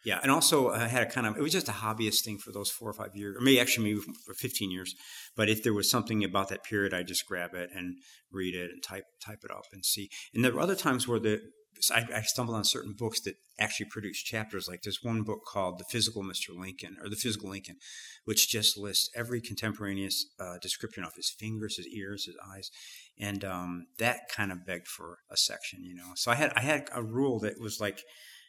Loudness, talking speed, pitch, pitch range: -31 LUFS, 240 wpm, 105 Hz, 95-115 Hz